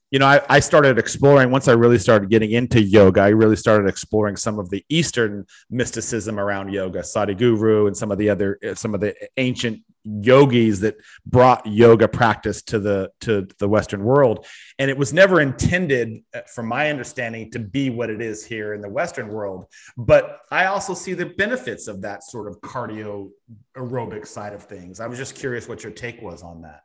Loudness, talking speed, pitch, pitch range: -18 LUFS, 200 wpm, 115 Hz, 105-130 Hz